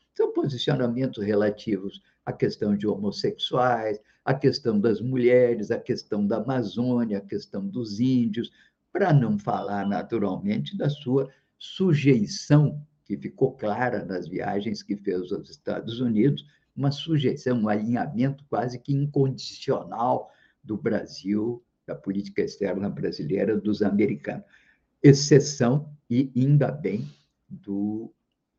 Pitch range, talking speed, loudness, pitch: 105-140 Hz, 120 wpm, -25 LUFS, 125 Hz